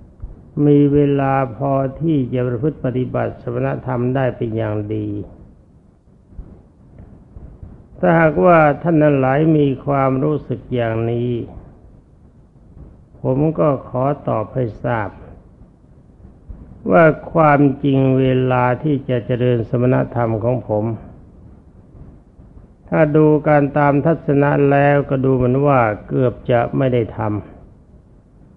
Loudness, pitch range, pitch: -17 LUFS, 115-145 Hz, 130 Hz